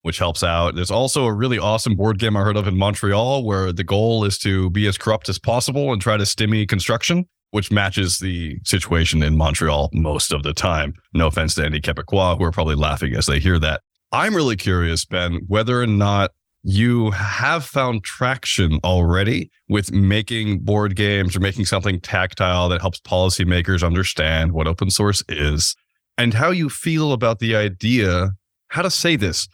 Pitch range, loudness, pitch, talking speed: 90-110 Hz, -19 LUFS, 100 Hz, 185 wpm